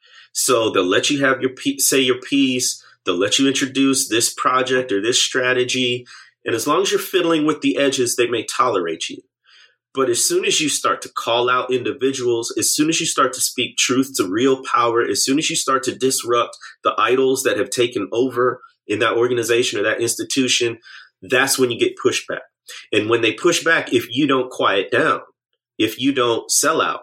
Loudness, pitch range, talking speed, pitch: -18 LUFS, 125-175 Hz, 200 wpm, 135 Hz